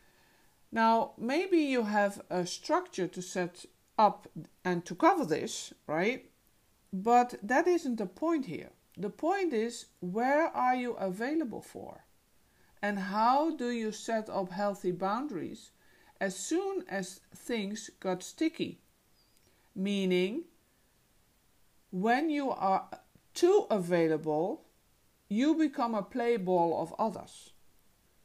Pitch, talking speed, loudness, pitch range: 220 Hz, 115 wpm, -31 LUFS, 190-280 Hz